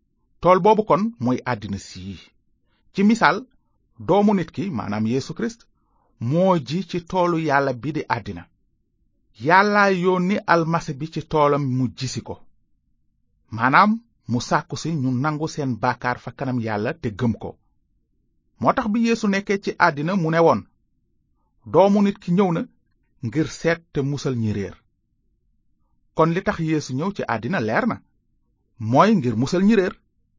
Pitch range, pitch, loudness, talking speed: 115-185 Hz, 145 Hz, -21 LUFS, 135 wpm